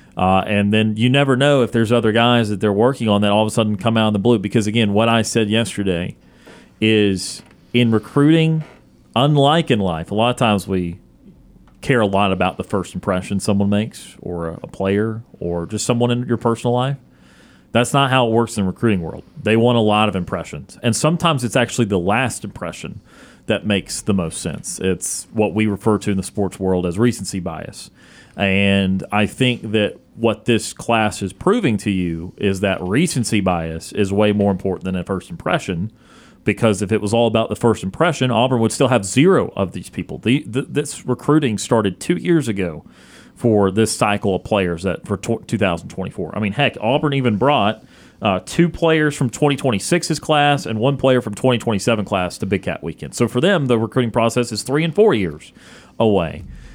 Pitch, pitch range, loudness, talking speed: 110 Hz, 100-125 Hz, -18 LUFS, 200 wpm